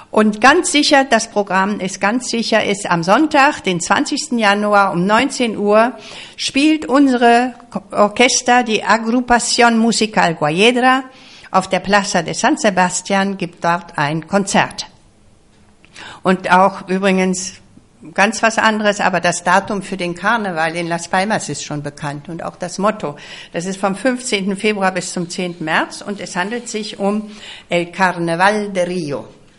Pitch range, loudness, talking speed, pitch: 180-230 Hz, -15 LUFS, 150 wpm, 200 Hz